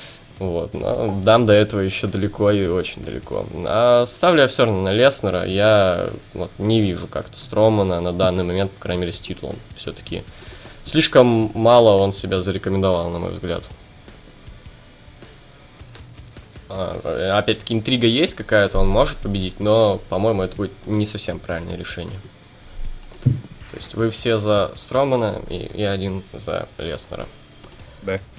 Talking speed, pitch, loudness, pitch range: 145 wpm, 100 Hz, -19 LUFS, 95-110 Hz